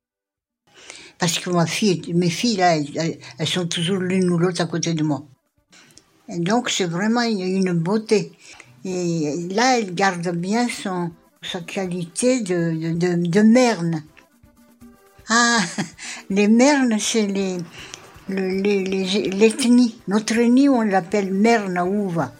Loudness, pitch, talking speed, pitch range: -20 LUFS, 185 Hz, 140 wpm, 170-215 Hz